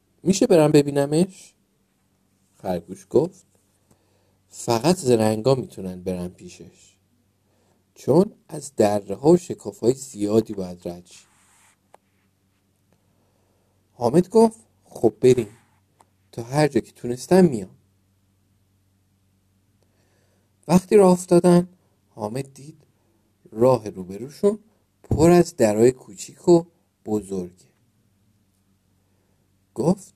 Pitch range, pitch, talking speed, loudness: 95-135 Hz, 105 Hz, 90 wpm, -20 LUFS